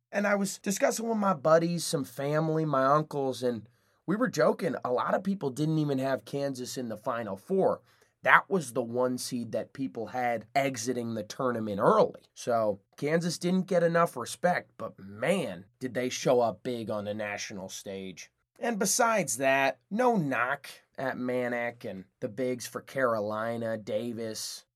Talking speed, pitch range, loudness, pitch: 165 wpm, 115-160 Hz, -29 LUFS, 130 Hz